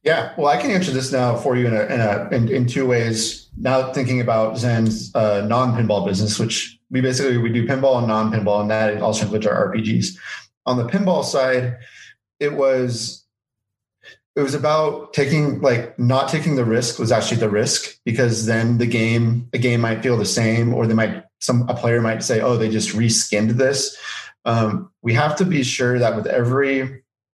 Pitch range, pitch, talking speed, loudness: 110-130 Hz, 120 Hz, 200 wpm, -19 LUFS